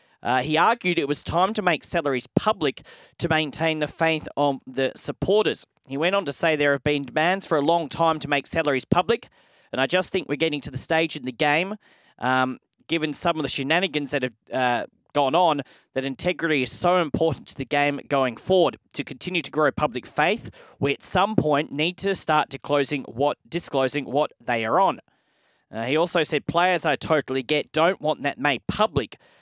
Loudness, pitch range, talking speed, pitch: -23 LUFS, 140-170 Hz, 205 wpm, 150 Hz